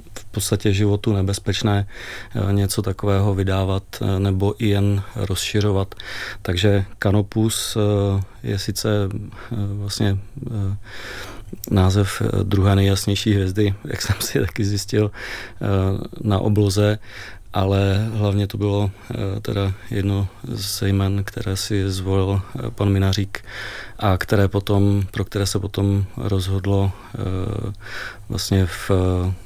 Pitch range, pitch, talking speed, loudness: 100-105 Hz, 100 Hz, 100 wpm, -21 LUFS